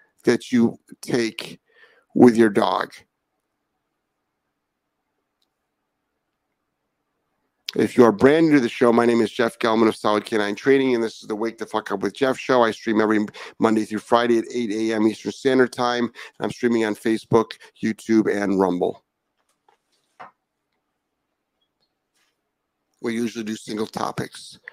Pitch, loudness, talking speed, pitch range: 115 Hz, -21 LUFS, 140 wpm, 110-120 Hz